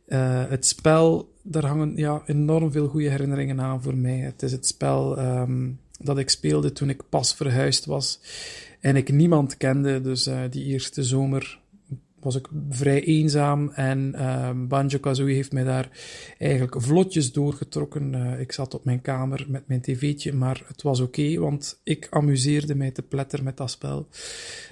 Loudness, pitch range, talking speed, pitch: -24 LUFS, 130-150 Hz, 170 wpm, 135 Hz